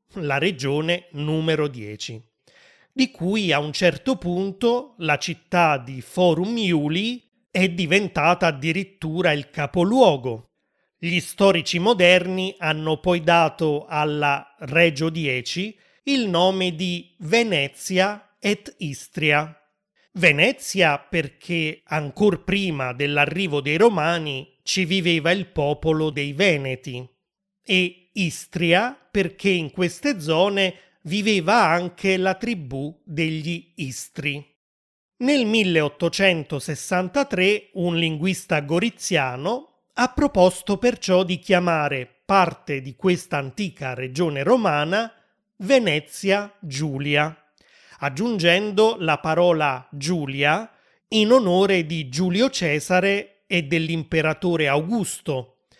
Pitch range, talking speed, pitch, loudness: 150-195 Hz, 95 wpm, 175 Hz, -21 LUFS